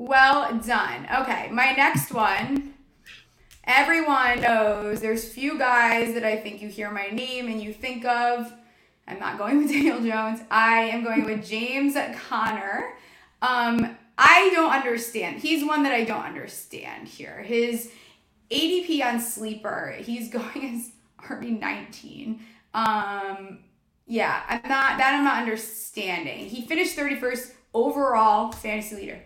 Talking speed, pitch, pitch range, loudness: 135 wpm, 235 Hz, 220-270 Hz, -23 LUFS